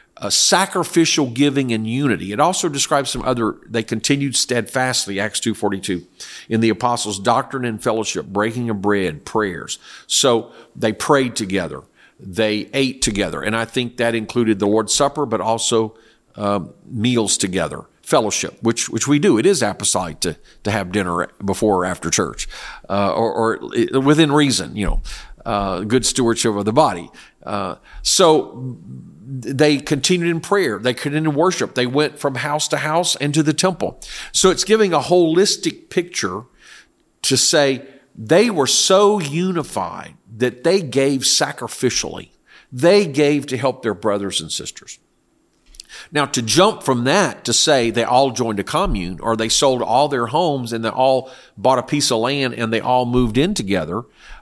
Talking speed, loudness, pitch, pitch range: 170 wpm, -18 LUFS, 125 Hz, 110-145 Hz